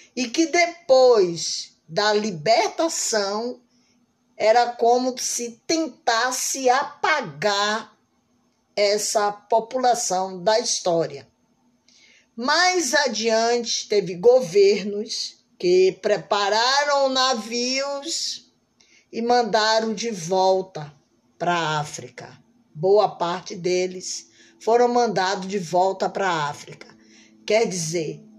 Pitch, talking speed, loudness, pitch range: 220 Hz, 85 wpm, -21 LUFS, 190-250 Hz